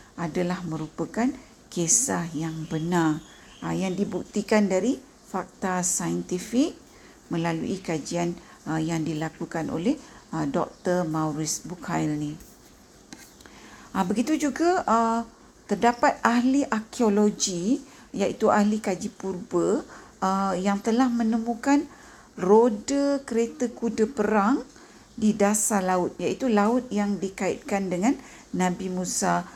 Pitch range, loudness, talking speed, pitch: 175-235 Hz, -25 LUFS, 90 wpm, 200 Hz